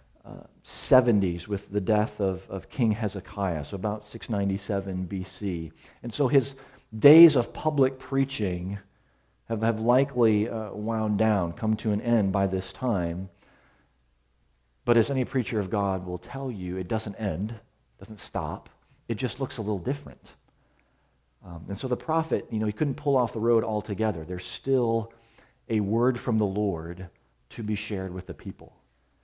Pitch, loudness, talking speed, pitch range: 105 Hz, -27 LUFS, 165 wpm, 95-120 Hz